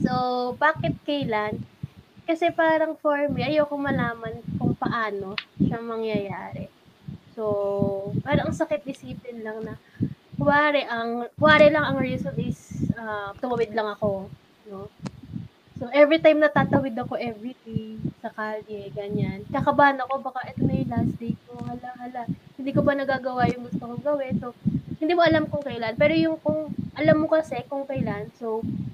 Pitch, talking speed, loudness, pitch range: 245 Hz, 155 wpm, -24 LUFS, 215-295 Hz